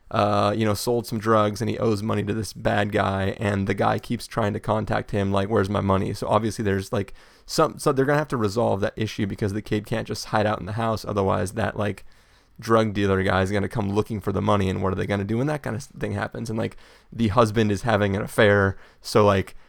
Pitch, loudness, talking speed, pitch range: 105 Hz, -24 LUFS, 255 wpm, 100-110 Hz